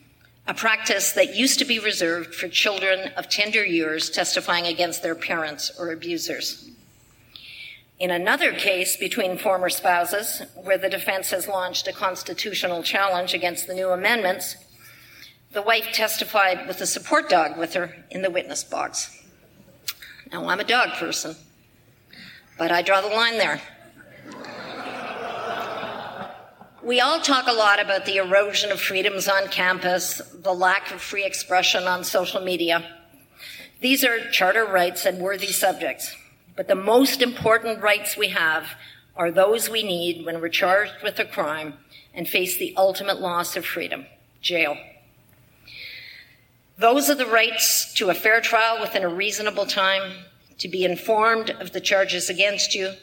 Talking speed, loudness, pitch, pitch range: 150 wpm, -22 LUFS, 190 Hz, 180-215 Hz